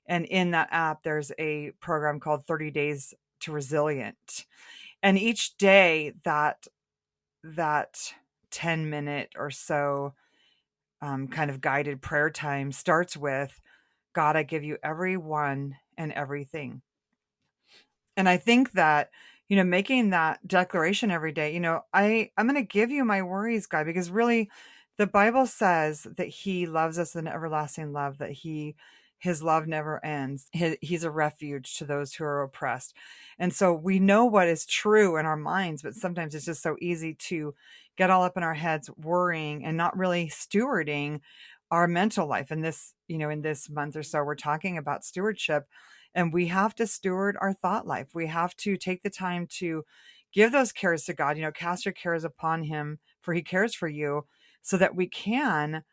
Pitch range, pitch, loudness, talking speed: 150-185 Hz, 165 Hz, -27 LUFS, 175 wpm